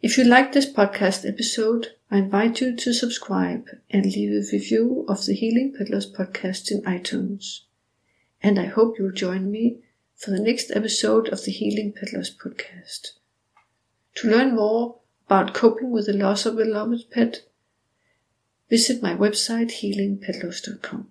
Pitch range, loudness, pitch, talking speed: 190-230 Hz, -22 LUFS, 210 Hz, 150 wpm